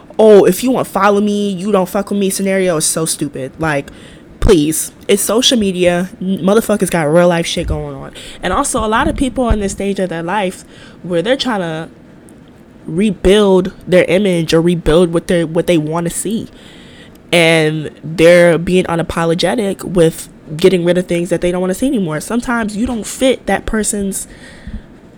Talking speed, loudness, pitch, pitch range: 185 wpm, -13 LUFS, 185 Hz, 170-205 Hz